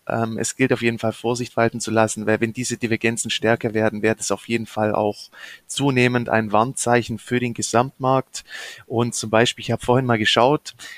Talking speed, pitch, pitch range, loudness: 190 wpm, 115 Hz, 110-120 Hz, -21 LUFS